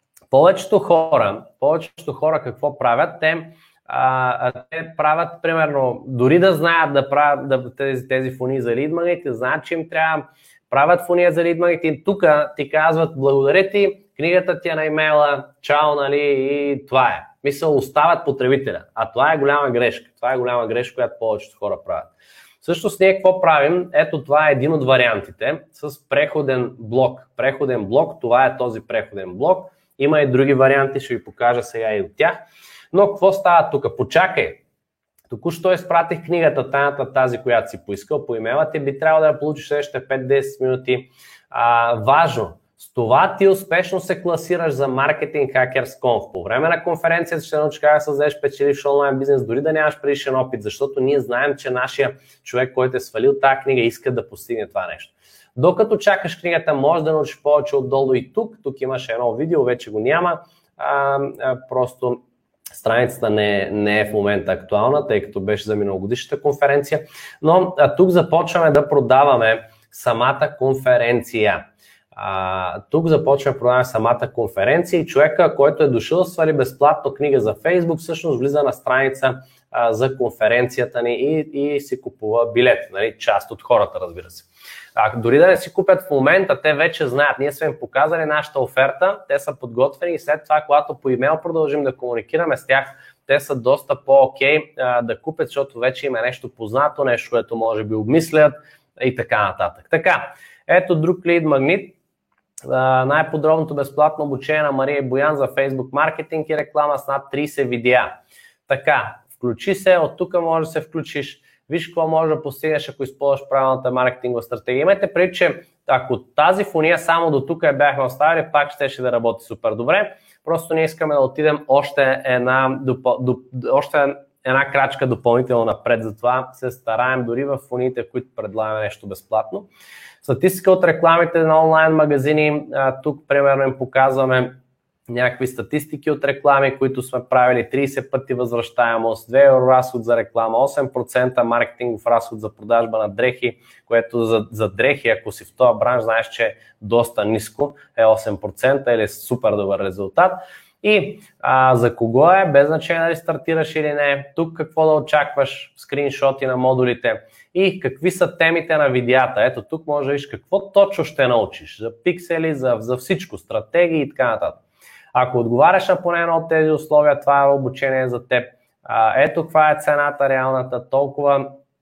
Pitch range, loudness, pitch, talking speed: 125-165 Hz, -18 LUFS, 140 Hz, 170 wpm